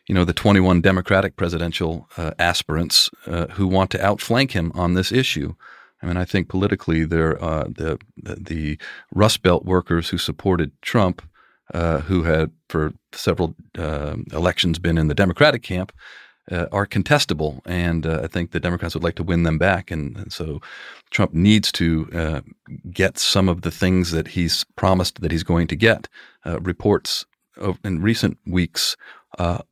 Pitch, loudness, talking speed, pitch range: 90 Hz, -20 LUFS, 175 wpm, 80-95 Hz